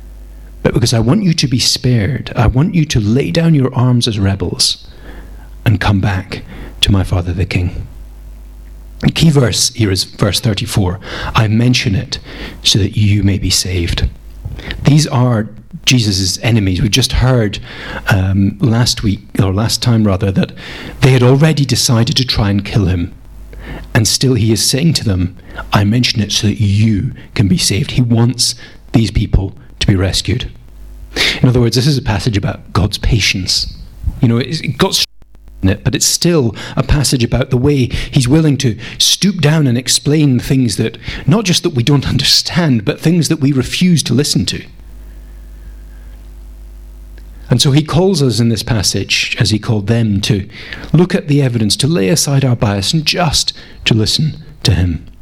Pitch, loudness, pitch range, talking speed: 115 Hz, -13 LUFS, 100-135 Hz, 175 wpm